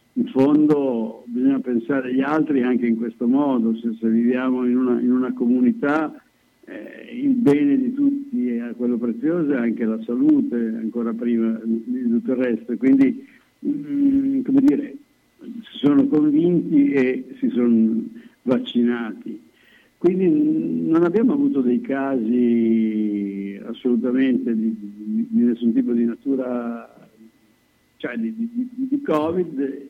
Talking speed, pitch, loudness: 130 wpm, 130 Hz, -20 LUFS